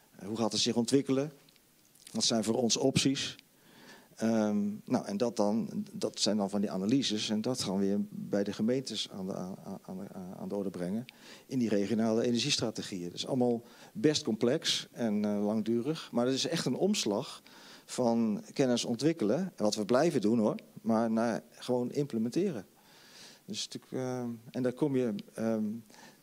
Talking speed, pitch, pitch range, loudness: 170 wpm, 120 Hz, 110-140 Hz, -32 LUFS